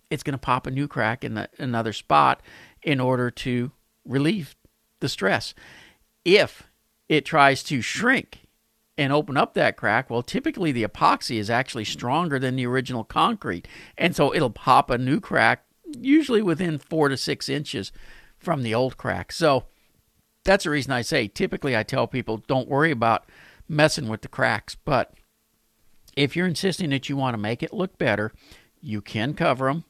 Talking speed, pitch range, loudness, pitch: 175 wpm, 115-155 Hz, -23 LUFS, 135 Hz